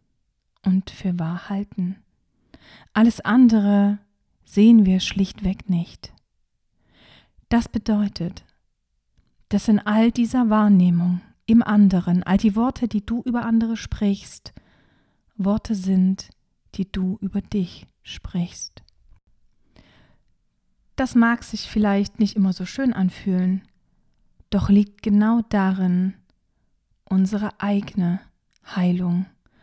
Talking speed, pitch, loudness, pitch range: 100 wpm, 200 Hz, -21 LUFS, 190-220 Hz